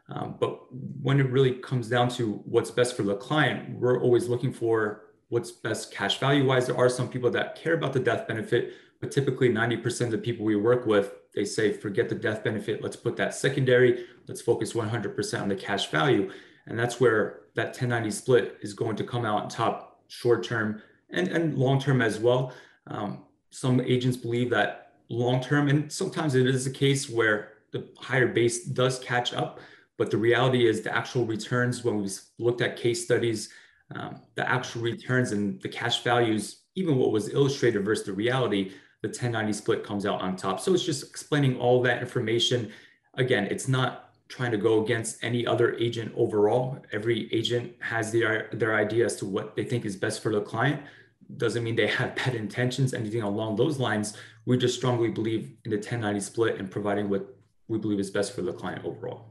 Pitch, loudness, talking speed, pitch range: 120 Hz, -27 LUFS, 195 wpm, 110-125 Hz